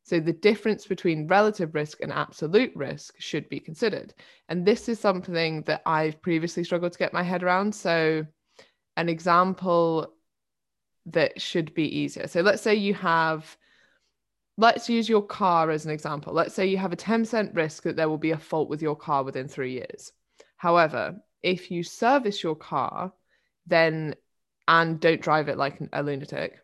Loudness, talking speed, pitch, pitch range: -25 LUFS, 175 wpm, 170 Hz, 155-190 Hz